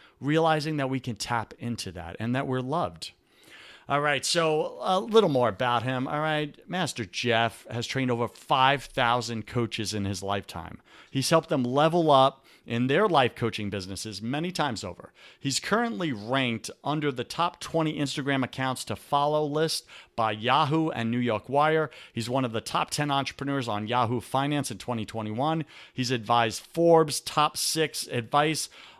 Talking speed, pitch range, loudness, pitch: 165 wpm, 115-150 Hz, -27 LUFS, 130 Hz